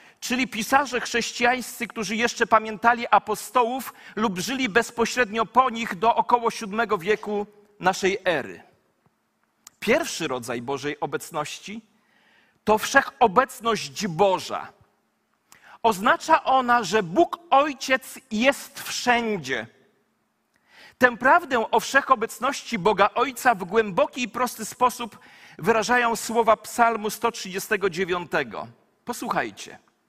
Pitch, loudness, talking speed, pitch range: 230 Hz, -23 LUFS, 95 wpm, 210-250 Hz